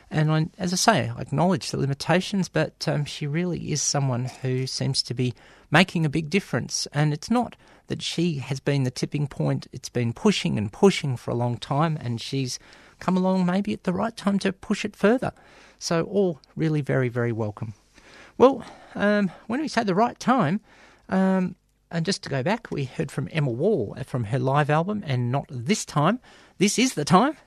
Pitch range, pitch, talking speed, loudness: 135-195 Hz, 155 Hz, 200 wpm, -25 LUFS